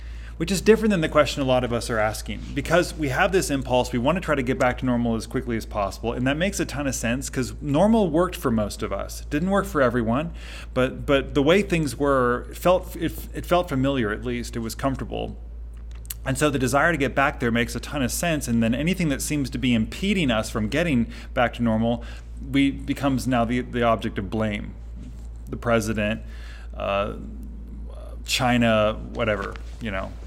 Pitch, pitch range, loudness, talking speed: 125 Hz, 110-145 Hz, -23 LUFS, 215 wpm